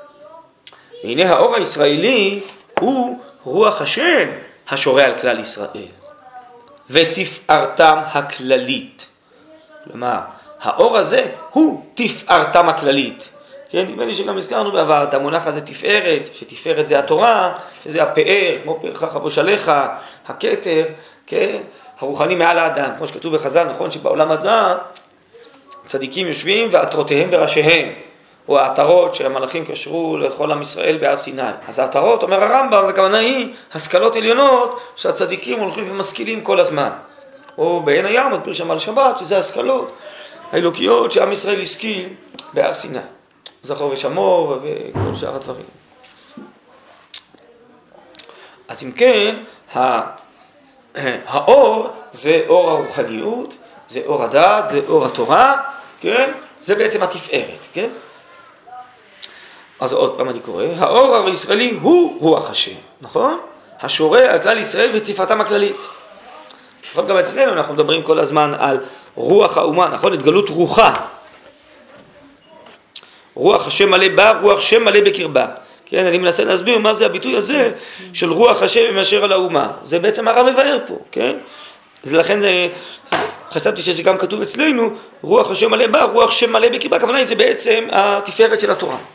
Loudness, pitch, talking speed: -15 LUFS, 280 Hz, 130 wpm